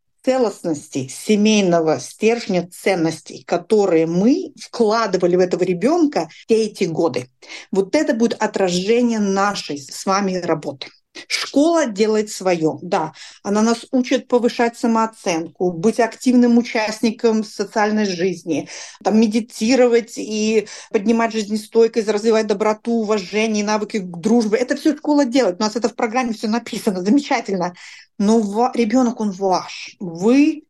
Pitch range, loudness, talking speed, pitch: 190-235 Hz, -18 LUFS, 125 wpm, 220 Hz